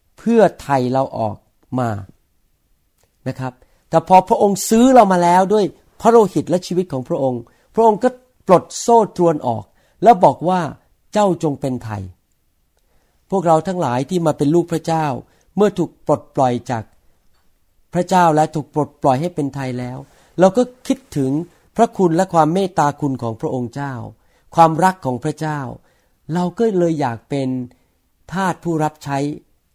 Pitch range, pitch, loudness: 125-180 Hz, 150 Hz, -17 LUFS